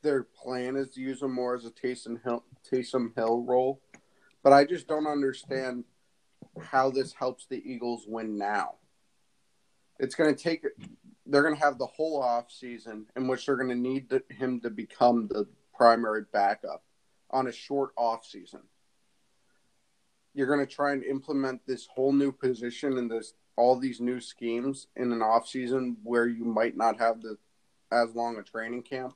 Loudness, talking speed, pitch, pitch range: -29 LUFS, 180 wpm, 125 Hz, 120-135 Hz